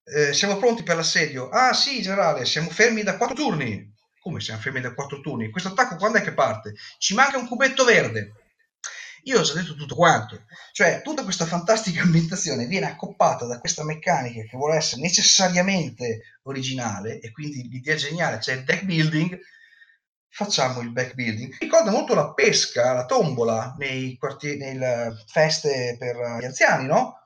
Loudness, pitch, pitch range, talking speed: -22 LUFS, 155 Hz, 125-195 Hz, 175 wpm